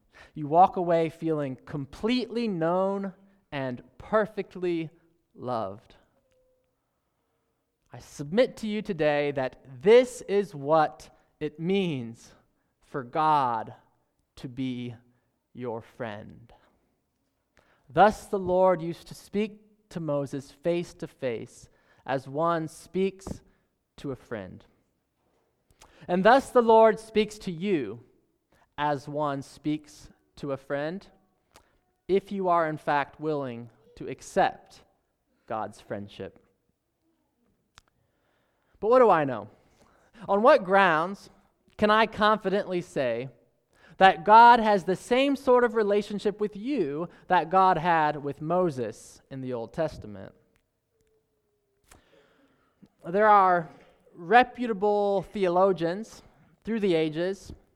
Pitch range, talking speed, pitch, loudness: 145-205 Hz, 110 wpm, 170 Hz, -25 LUFS